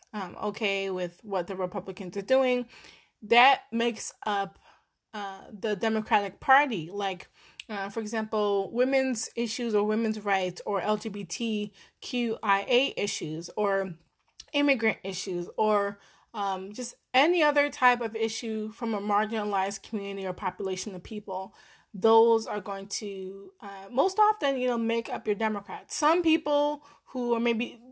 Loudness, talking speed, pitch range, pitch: -28 LUFS, 140 wpm, 195-240 Hz, 215 Hz